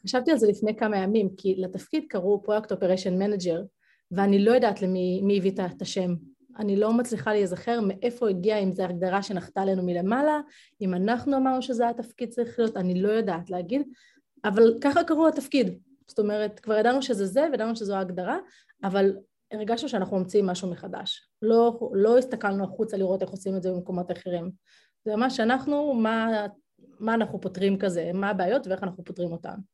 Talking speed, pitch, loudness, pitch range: 175 wpm, 205 Hz, -26 LUFS, 190-240 Hz